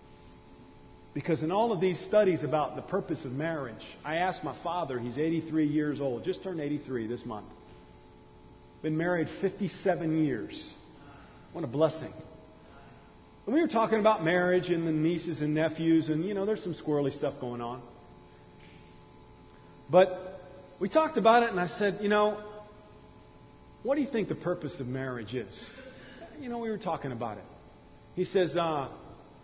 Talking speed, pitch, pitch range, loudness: 165 wpm, 160 Hz, 135-185 Hz, -30 LUFS